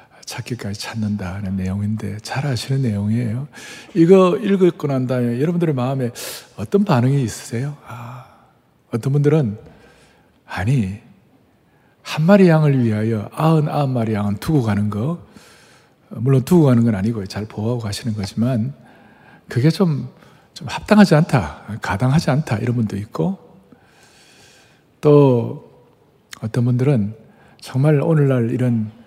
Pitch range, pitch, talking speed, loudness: 110-150 Hz, 125 Hz, 275 characters per minute, -18 LUFS